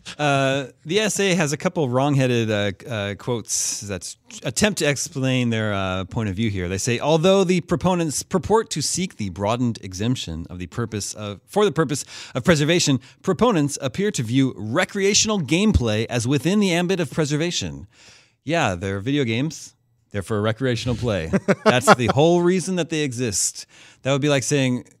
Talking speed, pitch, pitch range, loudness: 175 wpm, 135 Hz, 115-170 Hz, -21 LUFS